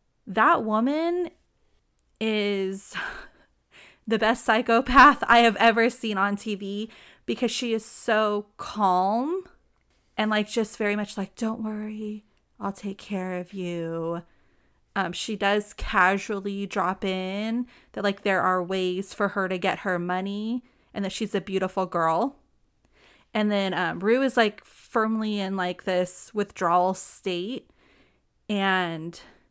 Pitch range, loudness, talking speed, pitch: 185-220 Hz, -25 LUFS, 135 wpm, 205 Hz